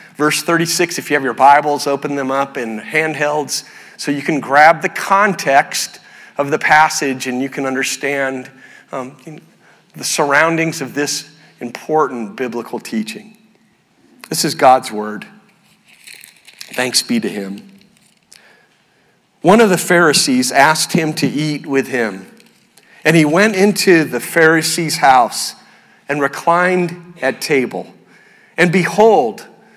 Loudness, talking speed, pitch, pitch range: -14 LUFS, 130 wpm, 155 Hz, 135-185 Hz